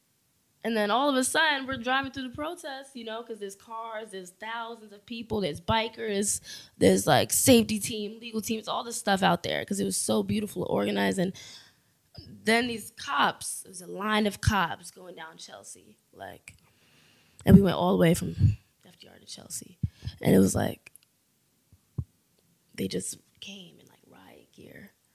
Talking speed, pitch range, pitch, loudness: 175 wpm, 190-235 Hz, 215 Hz, -27 LUFS